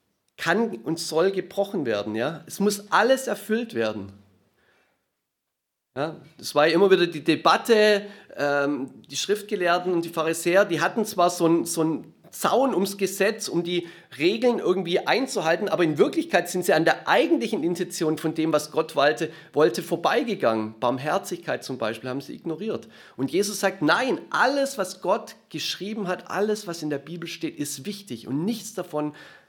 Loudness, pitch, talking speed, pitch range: -24 LUFS, 175 Hz, 165 wpm, 155-200 Hz